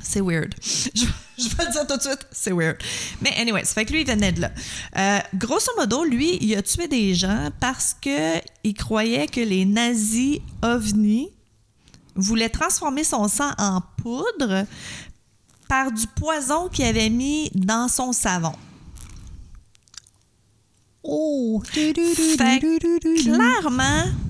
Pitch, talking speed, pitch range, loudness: 230 Hz, 140 wpm, 190-285 Hz, -21 LUFS